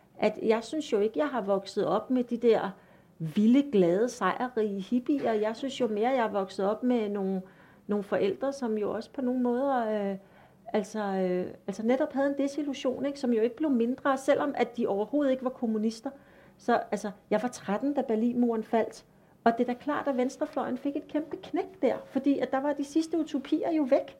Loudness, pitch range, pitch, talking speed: -29 LUFS, 210-275 Hz, 240 Hz, 215 wpm